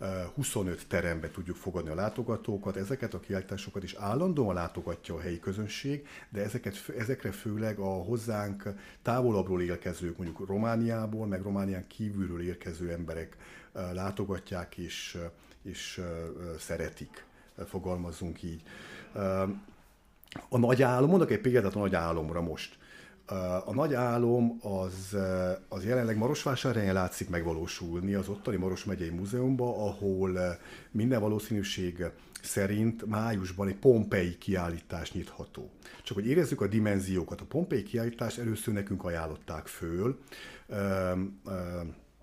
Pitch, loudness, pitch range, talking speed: 100 Hz, -33 LUFS, 90-110 Hz, 115 wpm